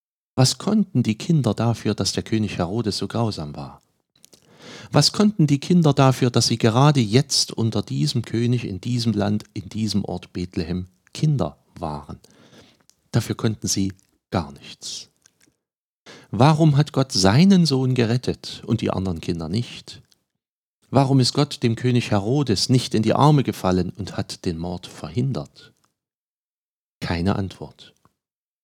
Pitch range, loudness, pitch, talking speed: 100-135 Hz, -21 LUFS, 115 Hz, 140 wpm